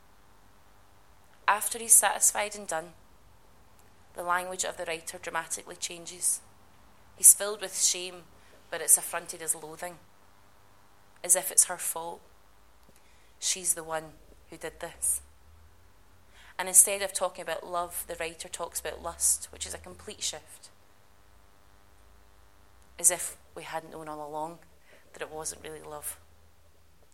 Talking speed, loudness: 135 wpm, -26 LUFS